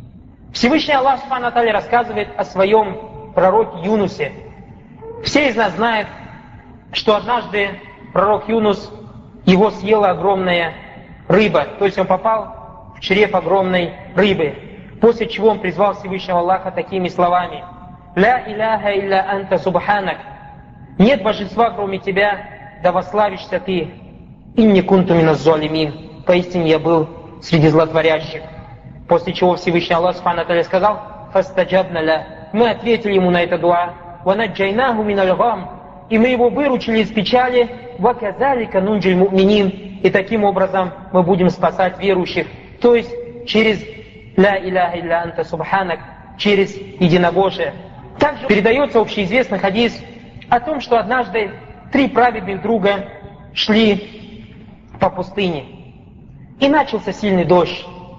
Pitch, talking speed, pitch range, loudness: 195 Hz, 115 wpm, 180-220 Hz, -16 LUFS